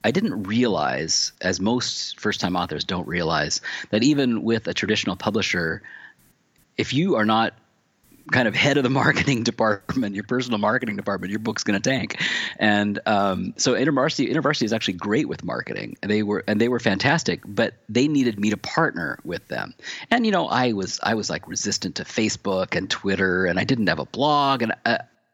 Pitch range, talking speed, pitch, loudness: 100-125 Hz, 190 wpm, 110 Hz, -22 LUFS